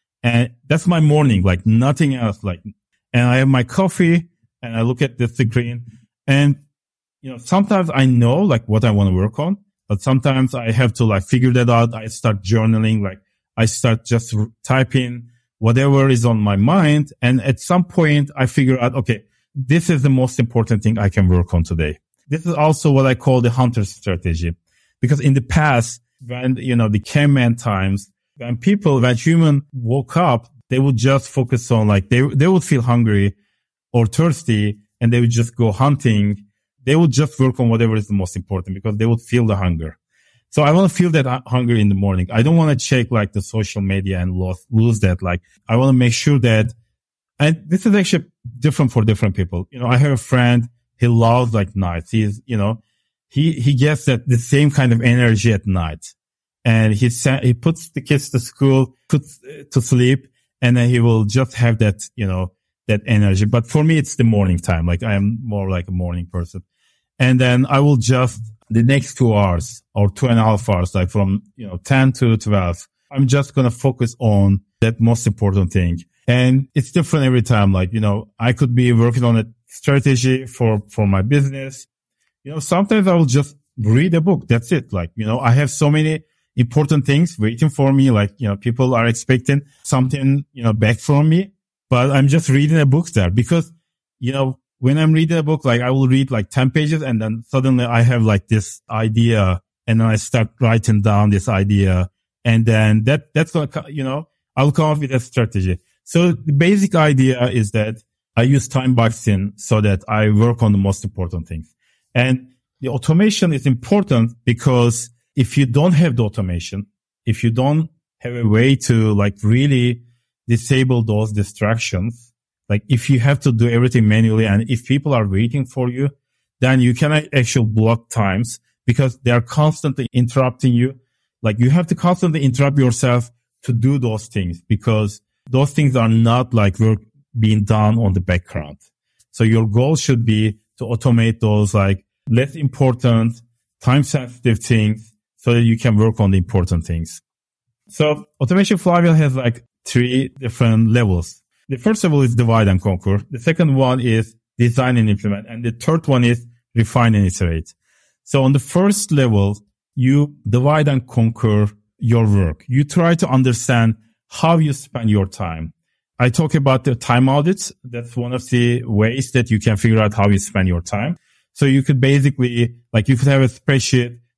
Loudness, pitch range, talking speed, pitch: -16 LUFS, 110-135 Hz, 195 wpm, 120 Hz